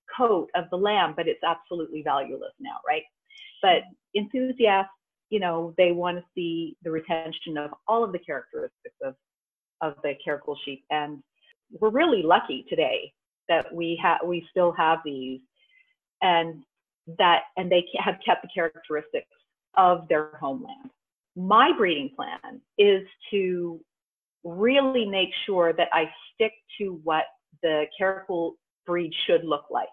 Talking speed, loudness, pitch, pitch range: 145 wpm, -25 LUFS, 180 Hz, 165-245 Hz